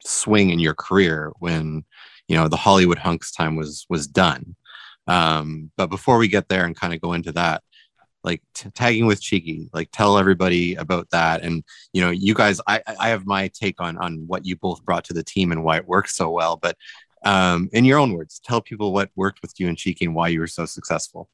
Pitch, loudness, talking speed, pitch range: 90 Hz, -21 LUFS, 230 wpm, 85-100 Hz